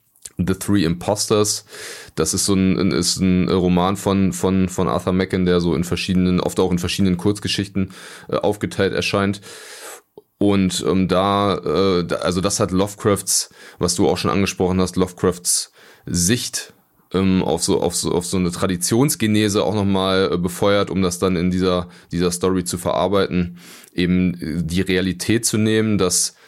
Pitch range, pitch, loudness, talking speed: 90-100 Hz, 95 Hz, -19 LUFS, 165 wpm